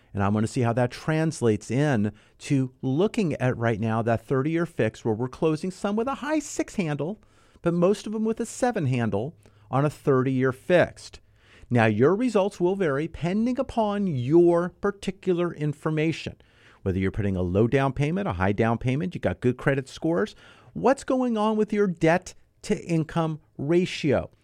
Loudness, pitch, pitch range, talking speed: -25 LUFS, 150 Hz, 115-185 Hz, 185 wpm